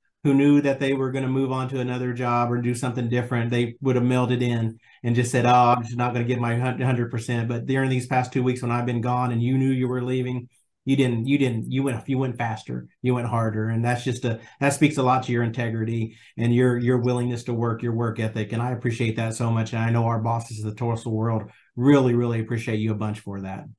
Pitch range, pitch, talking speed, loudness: 115-125 Hz, 120 Hz, 260 wpm, -24 LUFS